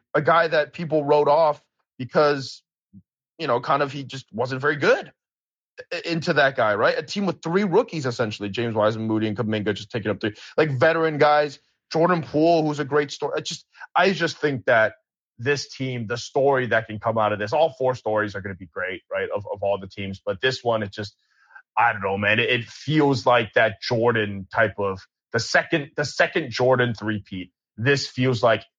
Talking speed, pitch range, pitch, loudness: 205 wpm, 110-150 Hz, 130 Hz, -22 LUFS